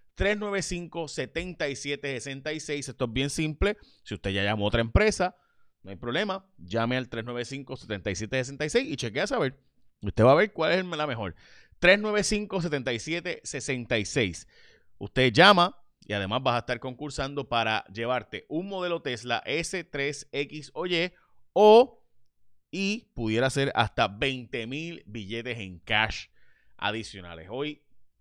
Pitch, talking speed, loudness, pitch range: 135 Hz, 125 wpm, -27 LUFS, 115-170 Hz